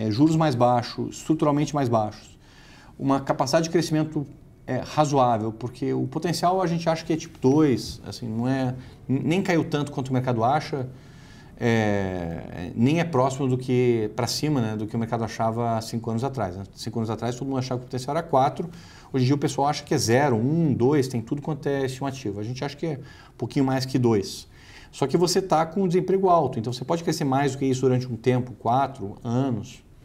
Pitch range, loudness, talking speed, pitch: 120-150 Hz, -24 LUFS, 215 wpm, 130 Hz